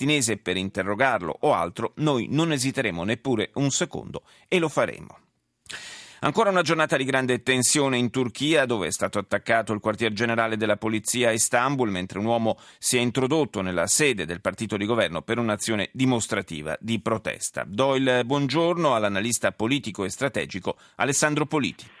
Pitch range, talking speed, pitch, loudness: 110-135 Hz, 160 wpm, 120 Hz, -24 LUFS